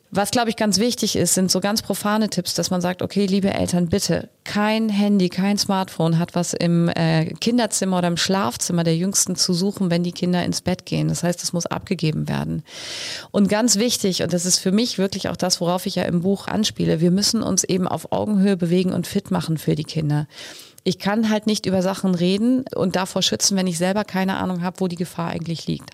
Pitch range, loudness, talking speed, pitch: 175-200 Hz, -21 LUFS, 225 wpm, 185 Hz